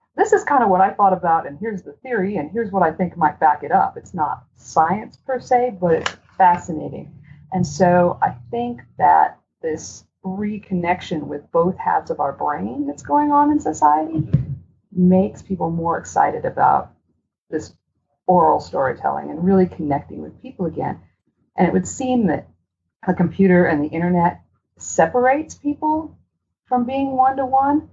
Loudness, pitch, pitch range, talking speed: -19 LUFS, 185 Hz, 165-260 Hz, 170 wpm